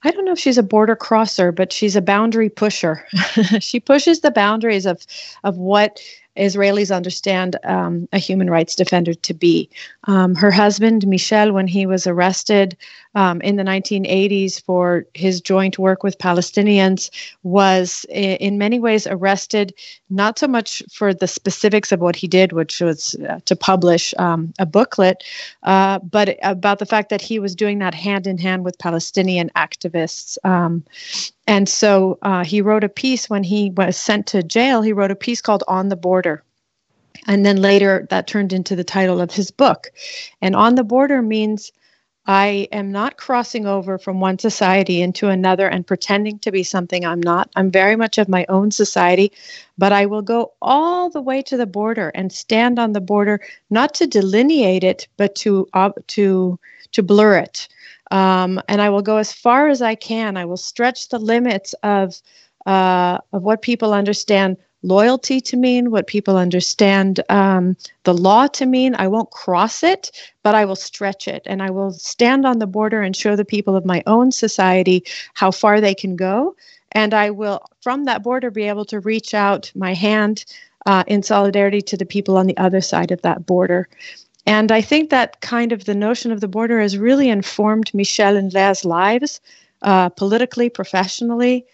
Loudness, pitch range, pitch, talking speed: -17 LUFS, 190-220 Hz, 200 Hz, 185 wpm